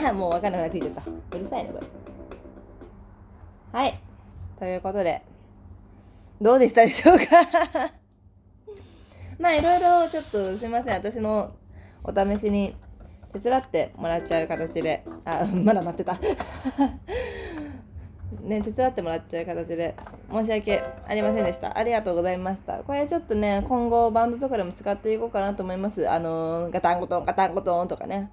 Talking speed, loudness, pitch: 340 characters per minute, -24 LUFS, 185 Hz